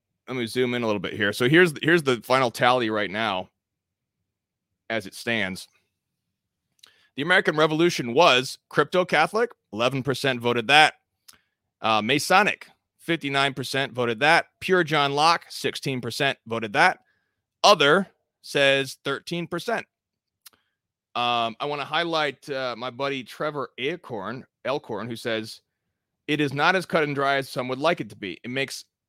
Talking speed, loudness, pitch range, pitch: 155 wpm, -23 LUFS, 120-155 Hz, 135 Hz